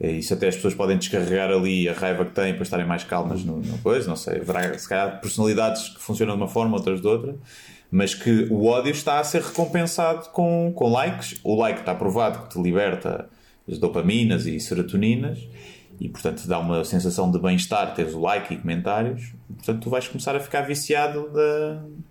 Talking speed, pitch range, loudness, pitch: 210 wpm, 90-145 Hz, -23 LUFS, 105 Hz